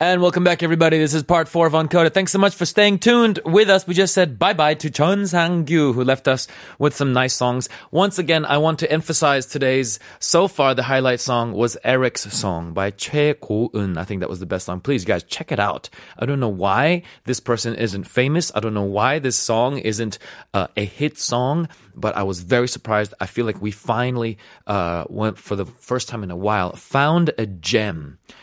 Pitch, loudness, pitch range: 130 Hz, -19 LUFS, 105-160 Hz